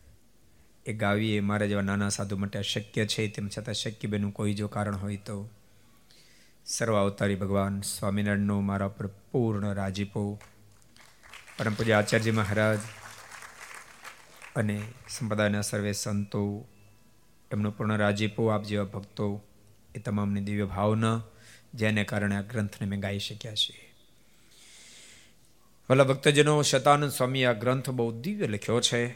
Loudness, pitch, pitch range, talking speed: -28 LUFS, 105 Hz, 100-115 Hz, 125 wpm